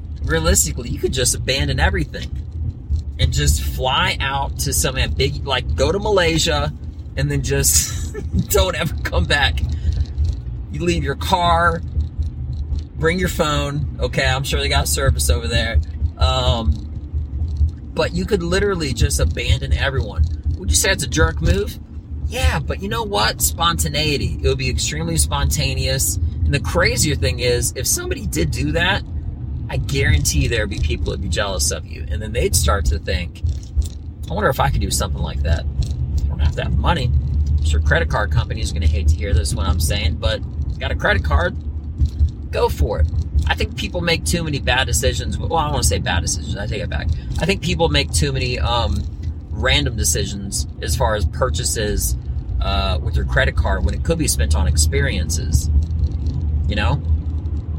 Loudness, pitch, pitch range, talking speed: -19 LUFS, 75 Hz, 75-80 Hz, 185 wpm